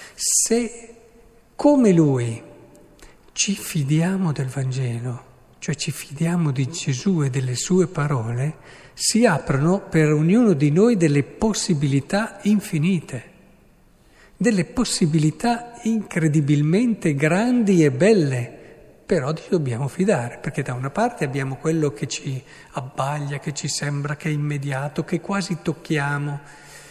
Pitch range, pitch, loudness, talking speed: 145-195 Hz, 155 Hz, -21 LUFS, 120 wpm